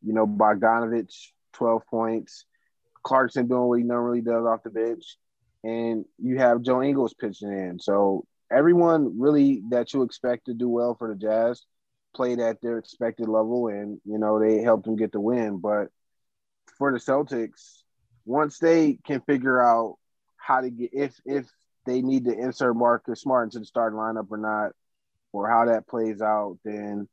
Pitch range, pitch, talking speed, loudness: 110-125 Hz, 115 Hz, 175 wpm, -24 LUFS